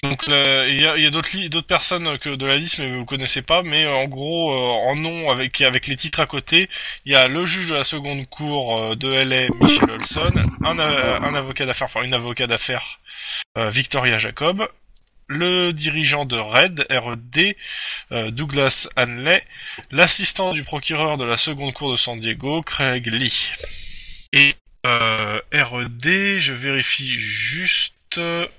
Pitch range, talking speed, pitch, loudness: 125-155 Hz, 175 wpm, 140 Hz, -18 LUFS